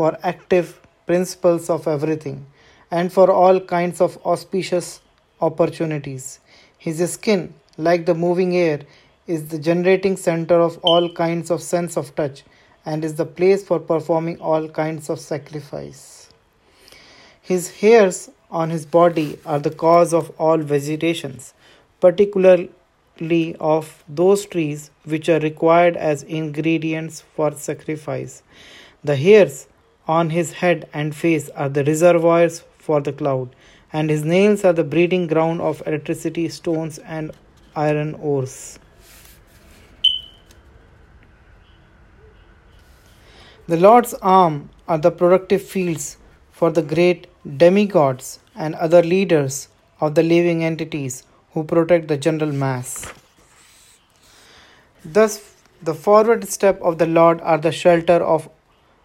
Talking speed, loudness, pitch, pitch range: 125 wpm, -18 LUFS, 165 Hz, 150-175 Hz